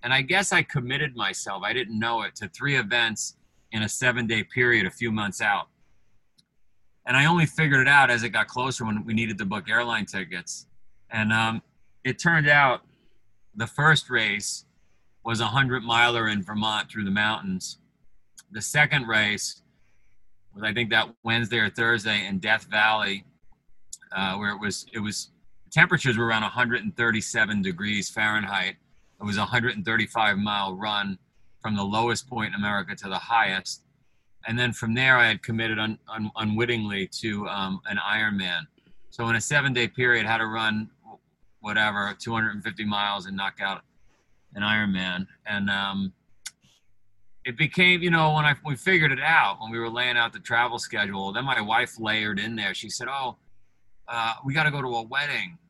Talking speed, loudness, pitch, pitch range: 175 wpm, -24 LUFS, 110 Hz, 105-125 Hz